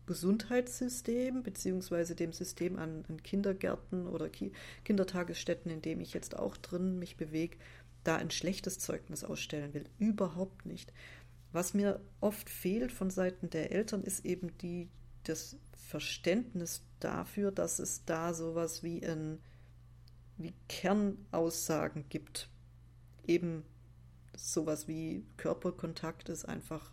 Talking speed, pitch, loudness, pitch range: 120 wpm, 170 Hz, -38 LUFS, 150-185 Hz